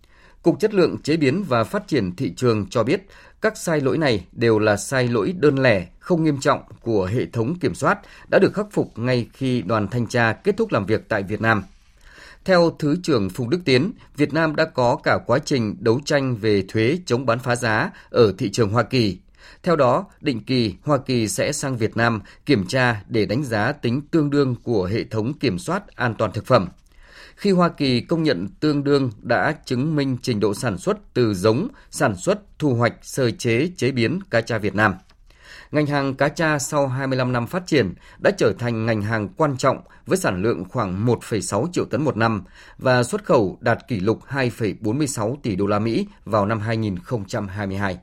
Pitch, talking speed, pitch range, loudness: 125 Hz, 205 wpm, 110-145 Hz, -21 LUFS